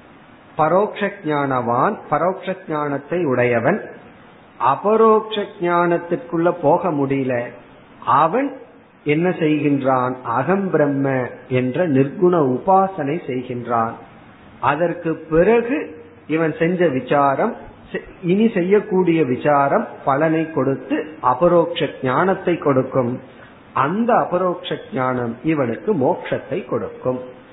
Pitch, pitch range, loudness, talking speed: 155 Hz, 130-175 Hz, -19 LUFS, 75 wpm